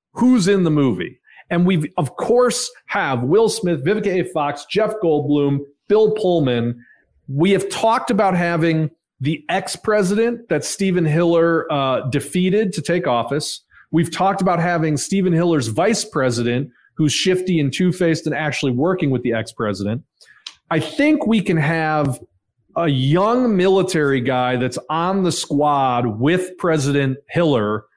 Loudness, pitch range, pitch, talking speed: -18 LUFS, 140-190 Hz, 165 Hz, 145 wpm